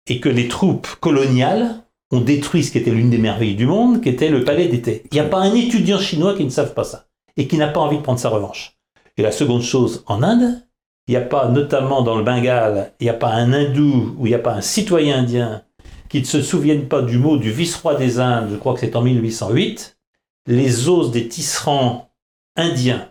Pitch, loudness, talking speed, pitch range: 130 Hz, -17 LUFS, 235 wpm, 120-155 Hz